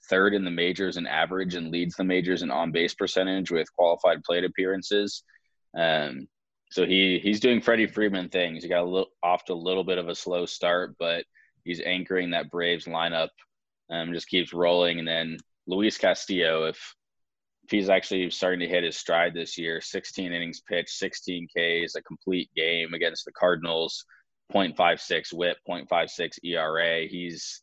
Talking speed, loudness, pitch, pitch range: 175 wpm, -26 LUFS, 85 Hz, 85-95 Hz